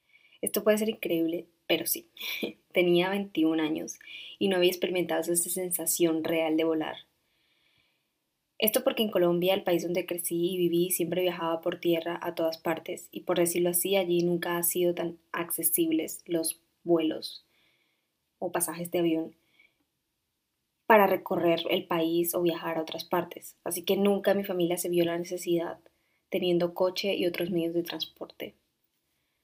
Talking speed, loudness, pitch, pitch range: 155 wpm, -28 LUFS, 175 Hz, 165-180 Hz